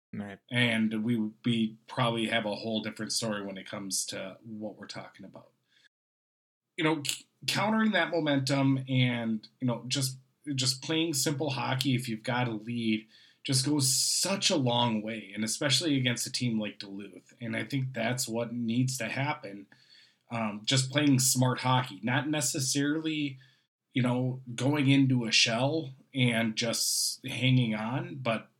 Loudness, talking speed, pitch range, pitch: -29 LUFS, 155 wpm, 115-135 Hz, 125 Hz